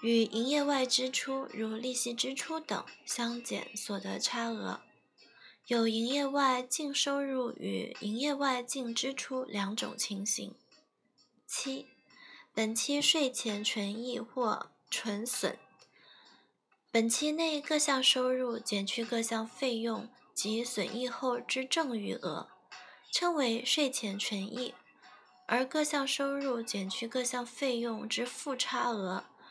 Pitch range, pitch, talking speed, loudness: 230-270 Hz, 245 Hz, 180 characters per minute, -33 LUFS